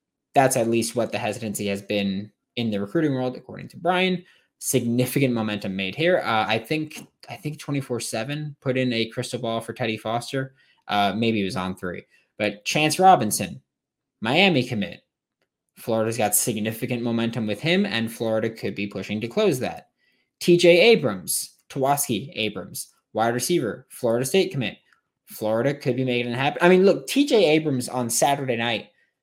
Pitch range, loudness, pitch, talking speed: 110-145 Hz, -23 LUFS, 120 Hz, 170 wpm